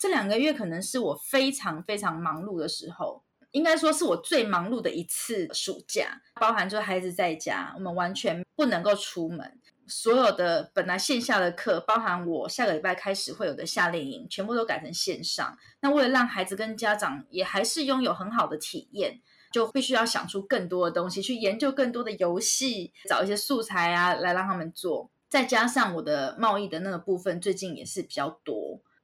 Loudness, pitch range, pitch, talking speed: -27 LUFS, 180-260 Hz, 210 Hz, 300 characters per minute